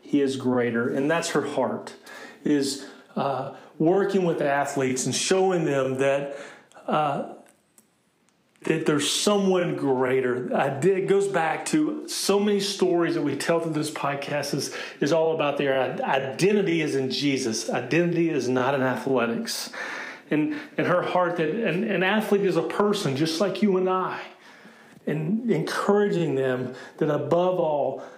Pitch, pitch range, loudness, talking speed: 160 Hz, 135-190 Hz, -24 LUFS, 155 wpm